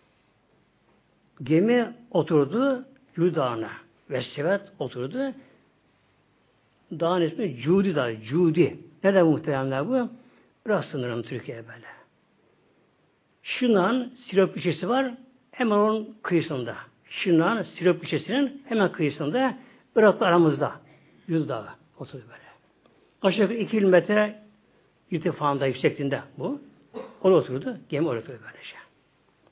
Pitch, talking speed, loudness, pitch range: 180 Hz, 95 wpm, -25 LUFS, 155-225 Hz